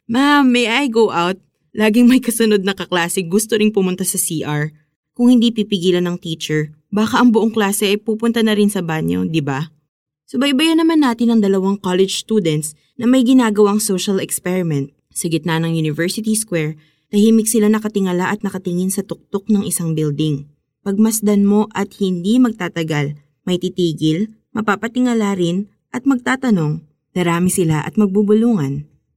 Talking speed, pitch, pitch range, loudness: 155 wpm, 195 Hz, 165-220 Hz, -16 LUFS